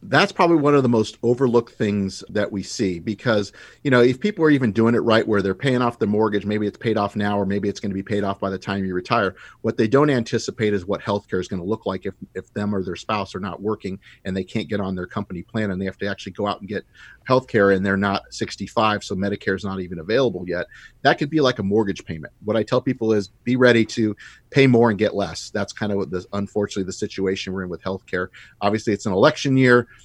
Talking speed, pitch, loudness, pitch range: 265 wpm, 105 Hz, -21 LUFS, 95-115 Hz